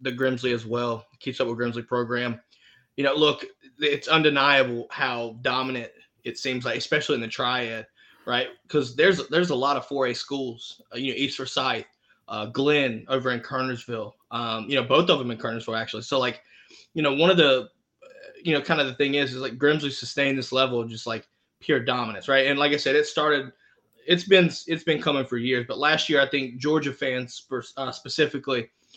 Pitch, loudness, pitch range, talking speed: 130 Hz, -24 LUFS, 120-145 Hz, 205 wpm